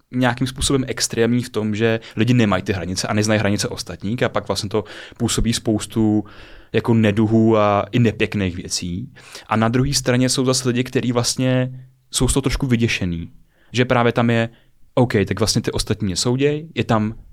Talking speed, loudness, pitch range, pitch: 180 wpm, -19 LUFS, 105-125 Hz, 115 Hz